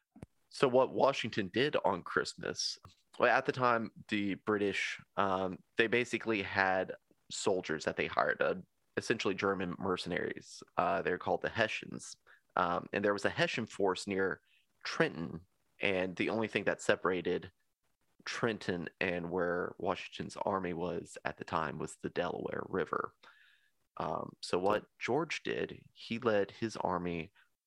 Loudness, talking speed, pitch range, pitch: -35 LUFS, 145 wpm, 95-115 Hz, 100 Hz